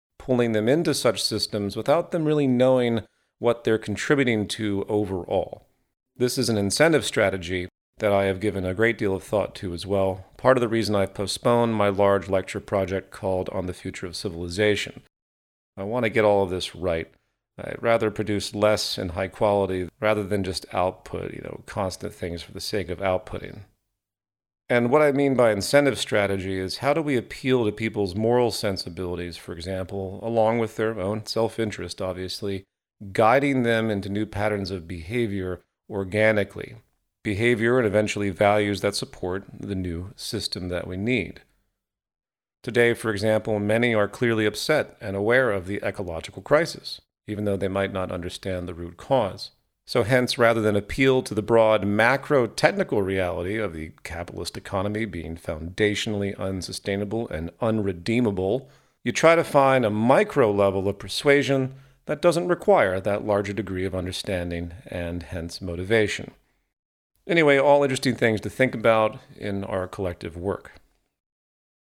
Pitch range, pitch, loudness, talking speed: 95-115 Hz, 105 Hz, -24 LUFS, 160 wpm